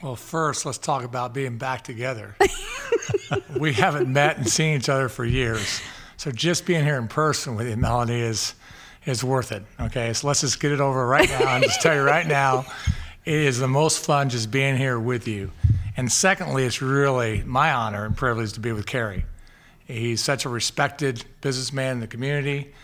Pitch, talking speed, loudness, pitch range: 130 Hz, 195 wpm, -23 LUFS, 115-145 Hz